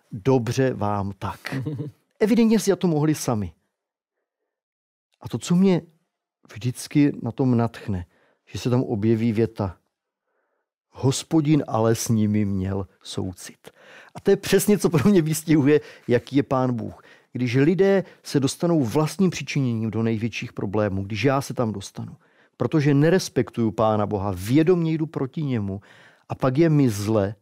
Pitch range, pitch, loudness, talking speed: 110-155 Hz, 130 Hz, -22 LUFS, 145 wpm